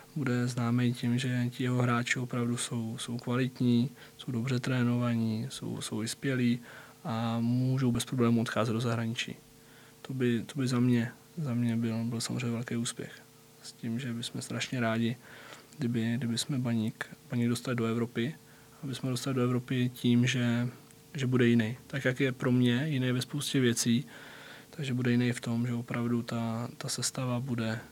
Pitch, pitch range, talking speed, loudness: 120 Hz, 115-125 Hz, 175 wpm, -31 LUFS